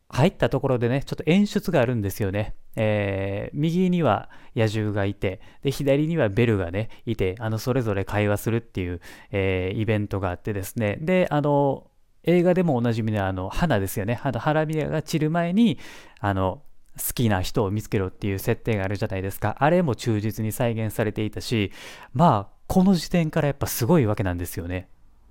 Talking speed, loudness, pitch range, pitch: 390 characters per minute, -24 LUFS, 100-145 Hz, 110 Hz